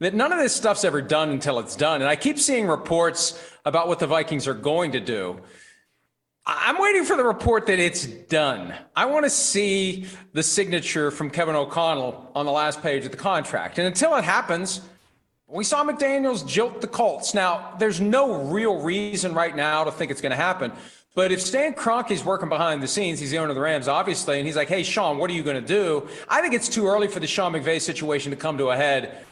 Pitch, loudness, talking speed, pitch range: 175 Hz, -23 LUFS, 225 wpm, 155-220 Hz